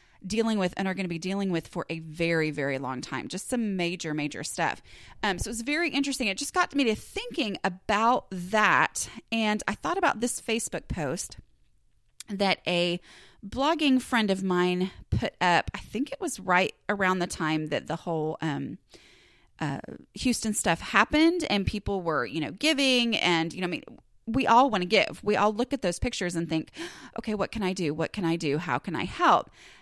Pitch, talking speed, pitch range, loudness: 195 Hz, 205 wpm, 170-240 Hz, -27 LUFS